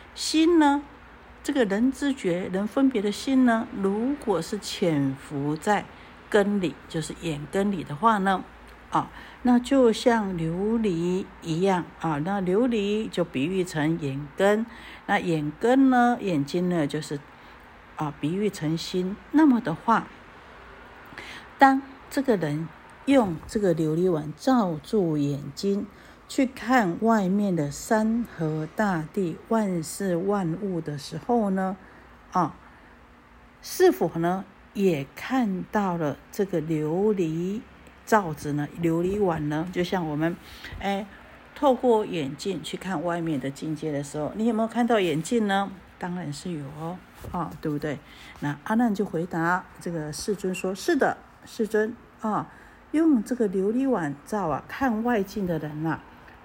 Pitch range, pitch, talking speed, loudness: 160-225 Hz, 190 Hz, 195 characters per minute, -26 LUFS